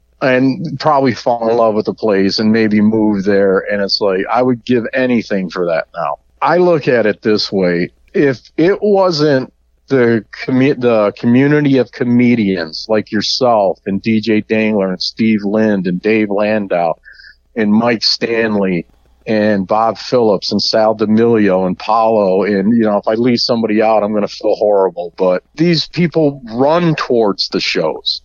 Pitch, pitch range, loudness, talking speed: 110 Hz, 100-125 Hz, -13 LUFS, 170 wpm